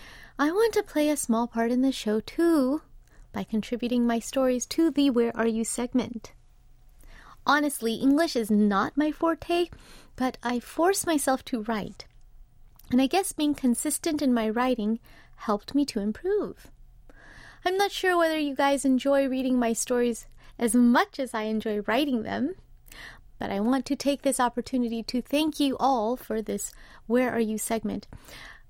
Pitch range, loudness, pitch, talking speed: 230-290 Hz, -26 LUFS, 255 Hz, 165 wpm